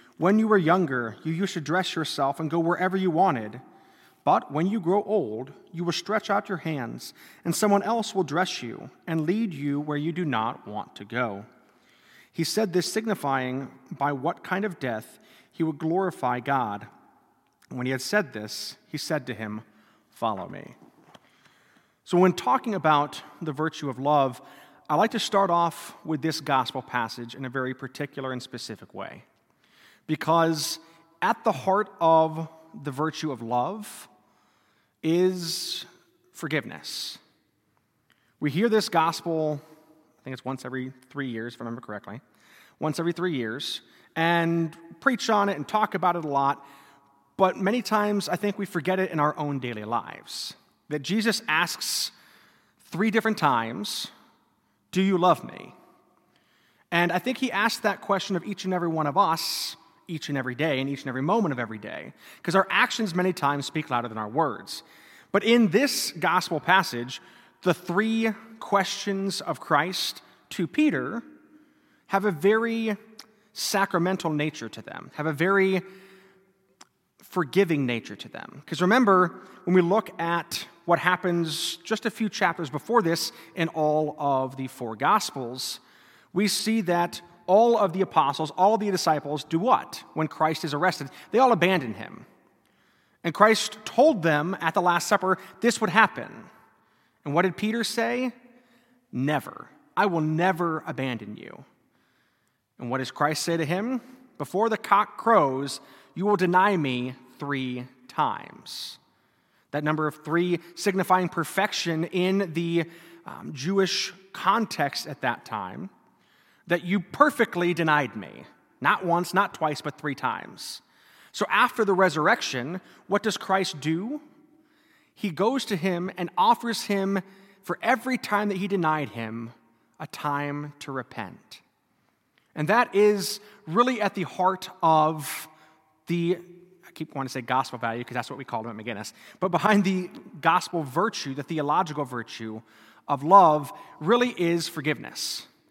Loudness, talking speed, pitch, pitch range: -26 LUFS, 160 wpm, 170 Hz, 145-200 Hz